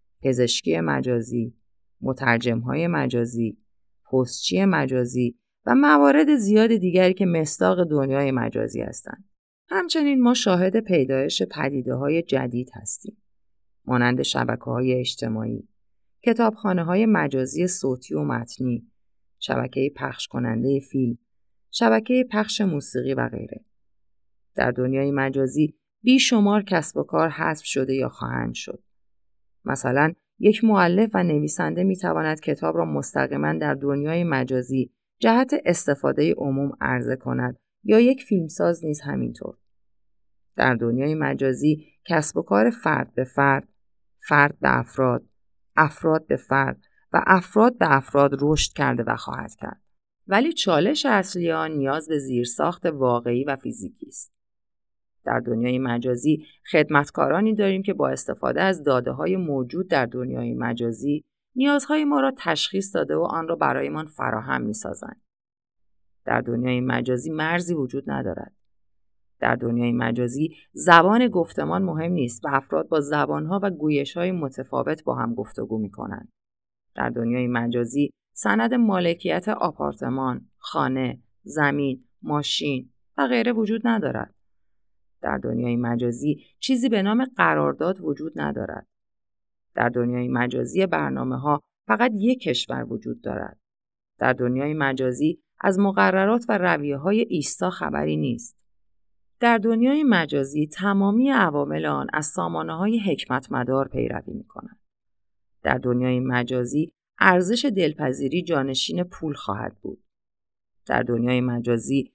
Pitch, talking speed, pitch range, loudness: 140 Hz, 125 wpm, 120-175 Hz, -22 LUFS